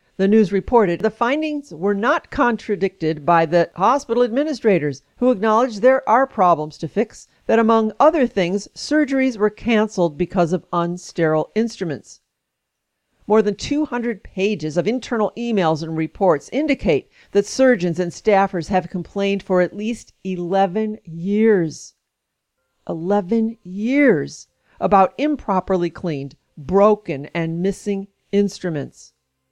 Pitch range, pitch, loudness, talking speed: 175-230 Hz, 200 Hz, -19 LUFS, 120 wpm